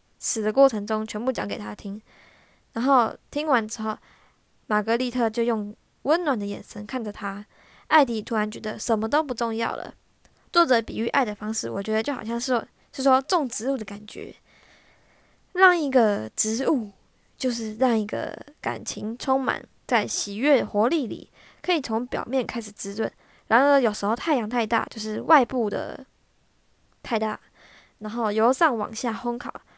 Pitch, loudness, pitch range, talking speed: 230 Hz, -24 LUFS, 215-260 Hz, 240 characters per minute